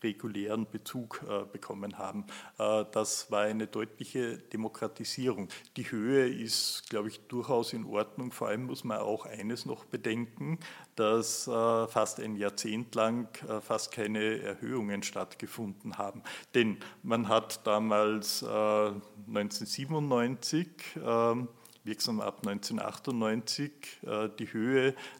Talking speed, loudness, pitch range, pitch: 105 wpm, -33 LUFS, 105-120 Hz, 110 Hz